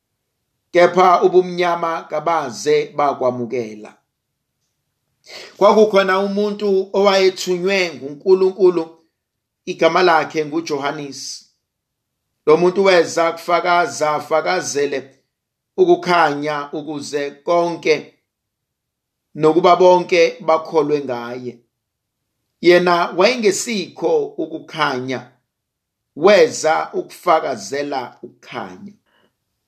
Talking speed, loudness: 65 wpm, -16 LUFS